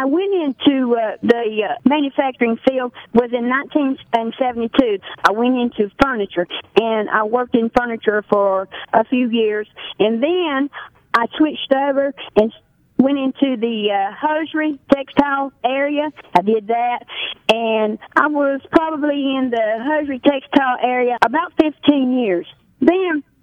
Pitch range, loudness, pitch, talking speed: 230-285 Hz, -18 LUFS, 260 Hz, 135 wpm